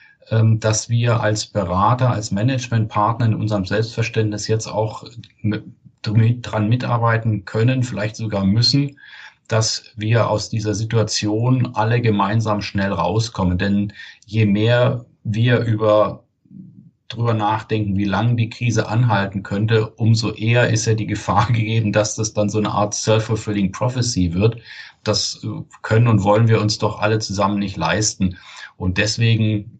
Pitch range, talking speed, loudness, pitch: 105-115 Hz, 140 wpm, -19 LUFS, 110 Hz